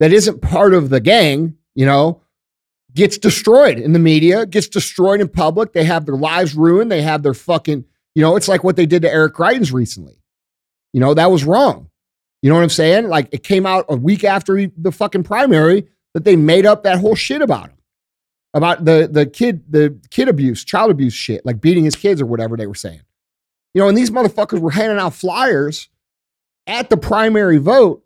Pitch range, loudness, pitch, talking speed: 140-195 Hz, -14 LUFS, 165 Hz, 210 wpm